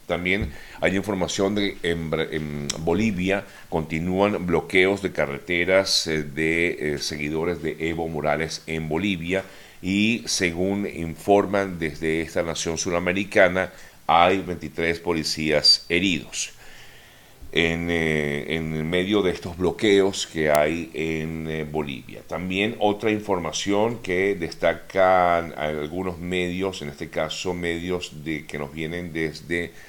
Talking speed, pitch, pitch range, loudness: 110 wpm, 85 Hz, 80-95 Hz, -23 LUFS